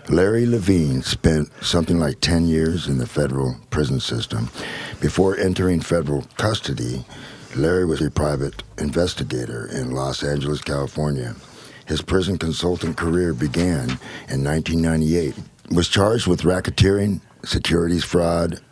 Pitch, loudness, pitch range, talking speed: 85 Hz, -21 LUFS, 75-90 Hz, 130 wpm